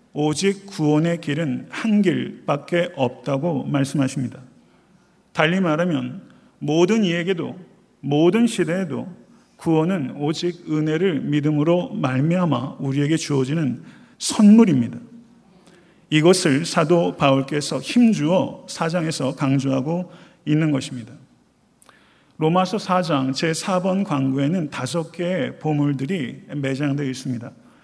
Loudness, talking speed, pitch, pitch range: -21 LUFS, 255 characters per minute, 160 Hz, 140-185 Hz